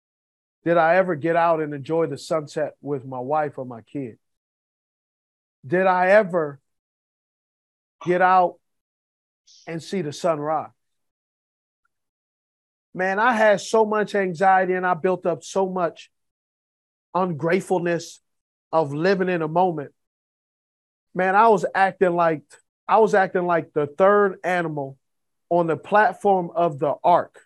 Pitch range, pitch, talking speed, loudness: 145-185 Hz, 170 Hz, 135 wpm, -21 LUFS